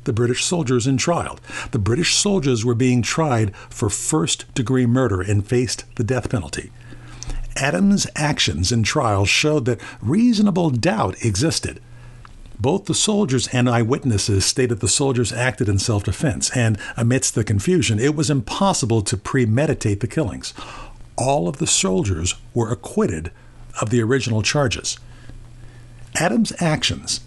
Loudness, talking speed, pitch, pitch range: -19 LUFS, 140 wpm, 125 Hz, 115-140 Hz